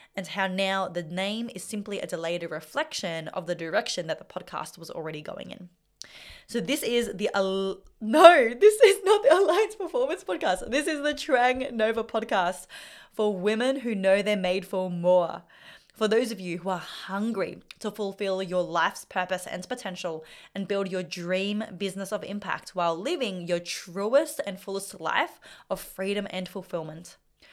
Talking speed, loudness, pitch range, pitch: 170 wpm, -26 LUFS, 180-225 Hz, 195 Hz